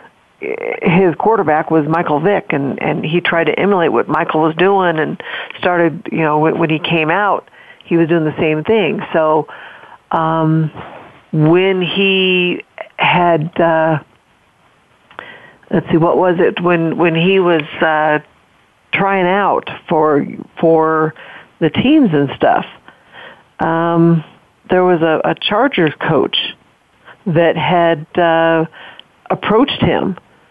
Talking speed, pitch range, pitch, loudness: 130 wpm, 160-180 Hz, 165 Hz, -14 LUFS